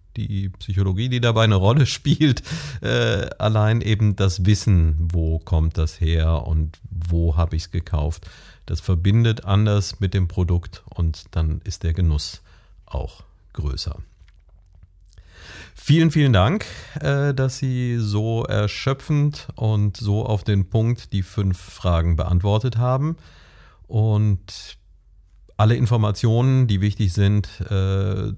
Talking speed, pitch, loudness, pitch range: 125 wpm, 100 Hz, -21 LUFS, 85-115 Hz